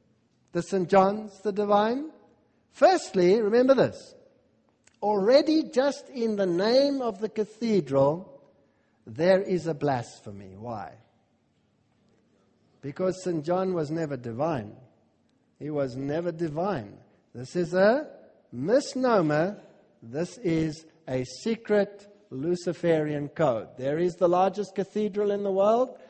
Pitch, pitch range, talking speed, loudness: 185 Hz, 150-210 Hz, 115 wpm, -26 LUFS